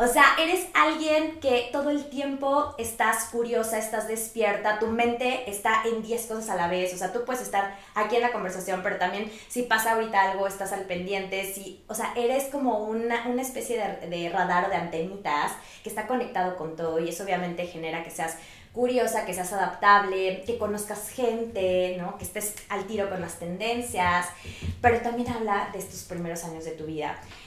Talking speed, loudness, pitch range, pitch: 190 wpm, -27 LUFS, 185-235 Hz, 210 Hz